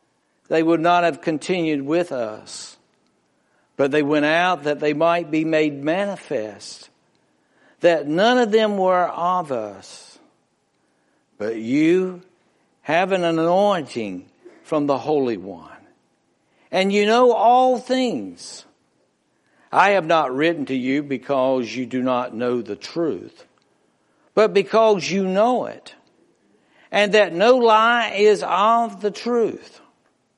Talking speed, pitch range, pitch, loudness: 125 wpm, 150-210 Hz, 175 Hz, -19 LUFS